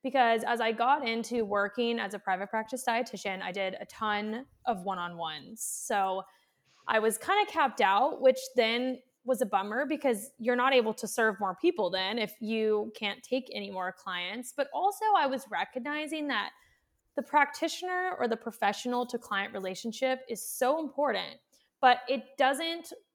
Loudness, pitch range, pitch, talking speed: -30 LUFS, 210-265 Hz, 240 Hz, 175 wpm